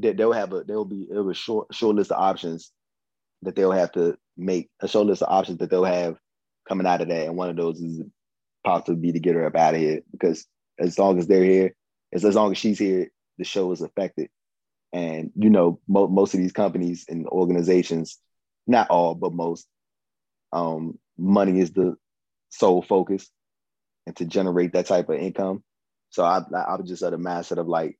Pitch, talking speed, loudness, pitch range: 90 Hz, 200 wpm, -23 LUFS, 85-95 Hz